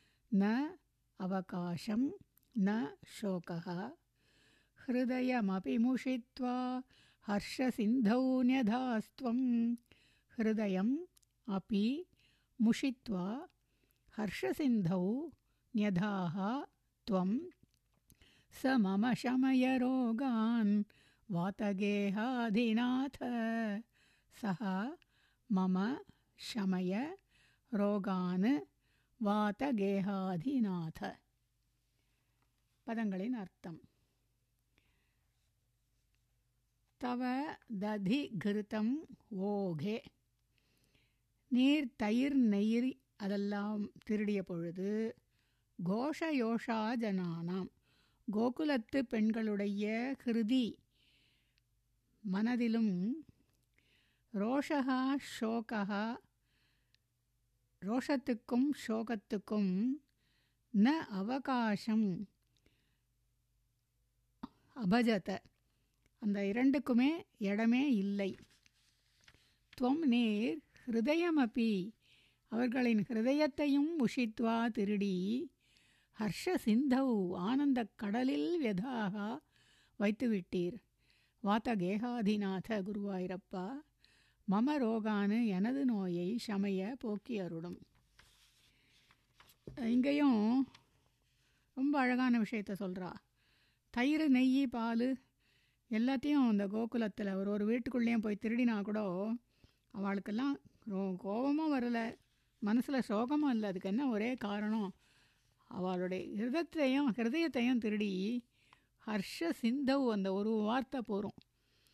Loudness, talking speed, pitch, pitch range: -36 LUFS, 60 wpm, 215 Hz, 190-250 Hz